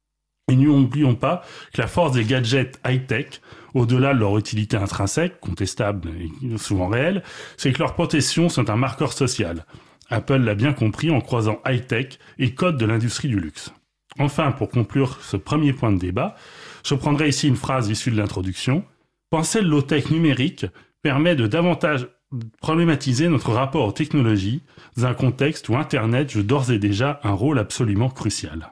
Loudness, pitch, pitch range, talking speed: -21 LUFS, 130 Hz, 110-150 Hz, 165 wpm